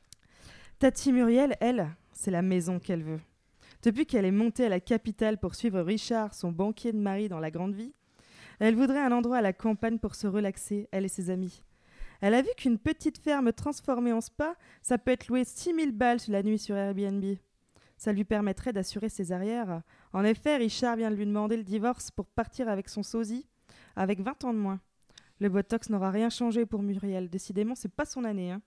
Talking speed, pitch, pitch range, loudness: 205 wpm, 215 Hz, 195-240 Hz, -30 LUFS